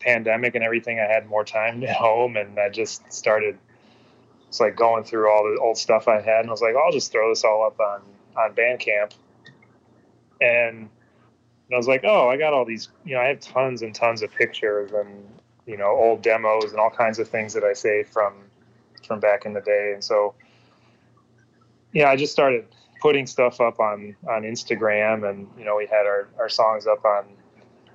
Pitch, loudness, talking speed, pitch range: 115 Hz, -21 LUFS, 205 wpm, 105-120 Hz